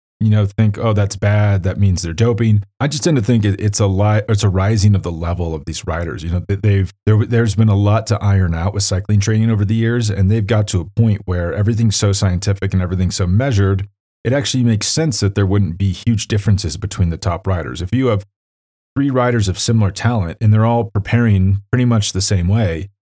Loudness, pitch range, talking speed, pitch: -16 LUFS, 95-110 Hz, 230 wpm, 100 Hz